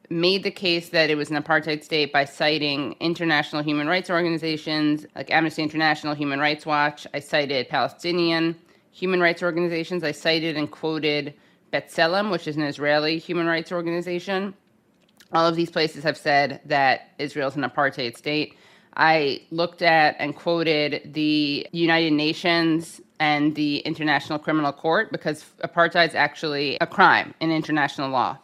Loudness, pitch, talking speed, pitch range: -22 LUFS, 155 Hz, 155 wpm, 150-170 Hz